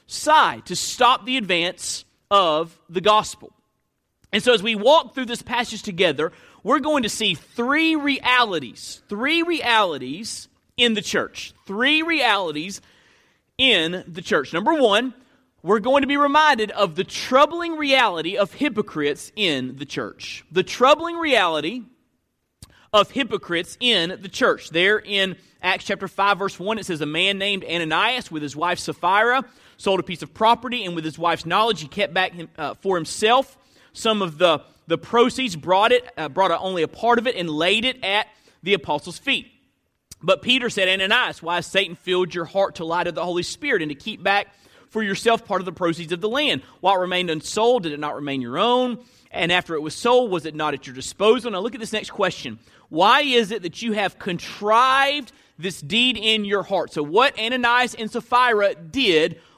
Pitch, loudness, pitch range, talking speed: 200 Hz, -20 LUFS, 175-245 Hz, 185 wpm